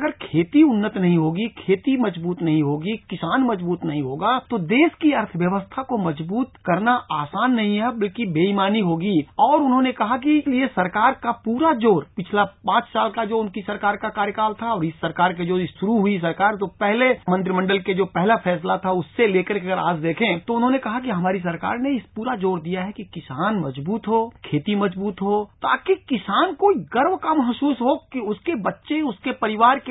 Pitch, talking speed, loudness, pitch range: 210 Hz, 195 wpm, -21 LUFS, 185-250 Hz